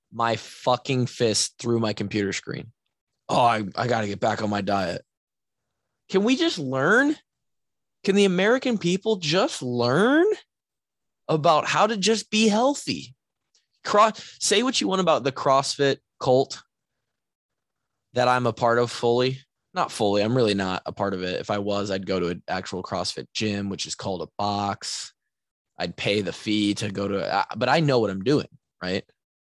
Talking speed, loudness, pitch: 175 wpm, -24 LUFS, 120 Hz